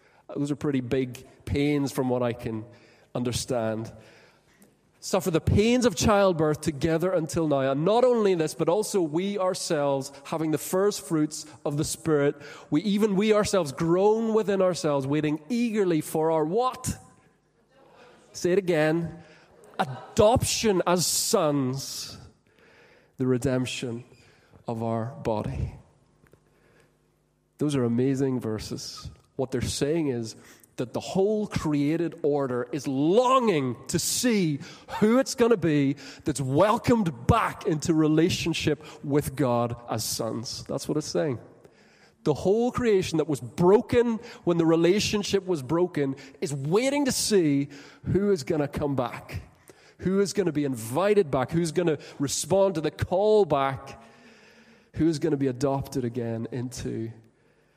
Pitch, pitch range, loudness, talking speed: 155 Hz, 135-185 Hz, -26 LUFS, 140 wpm